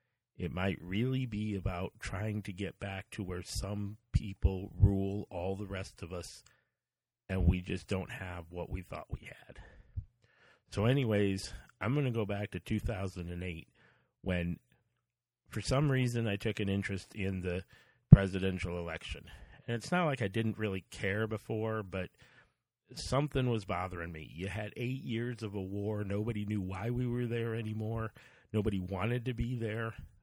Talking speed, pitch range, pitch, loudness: 165 wpm, 95-115 Hz, 105 Hz, -35 LUFS